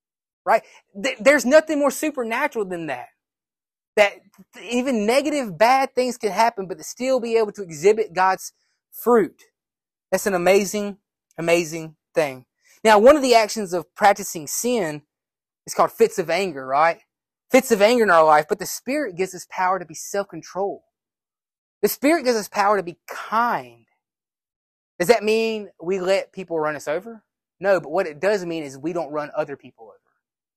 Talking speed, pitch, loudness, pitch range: 175 wpm, 200 Hz, -21 LUFS, 175-235 Hz